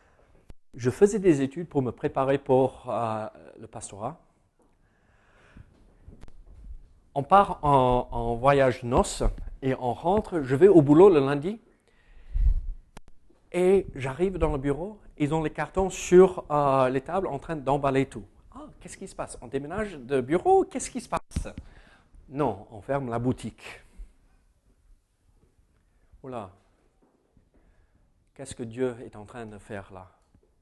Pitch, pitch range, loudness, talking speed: 130 Hz, 100-155 Hz, -25 LUFS, 140 wpm